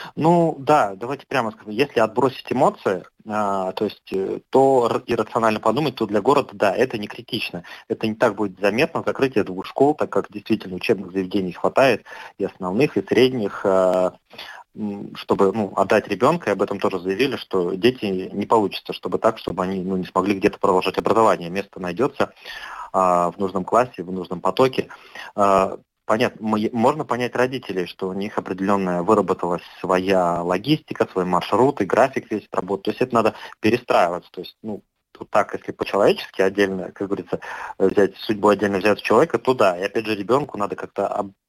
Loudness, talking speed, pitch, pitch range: -21 LUFS, 165 wpm, 100 Hz, 95-110 Hz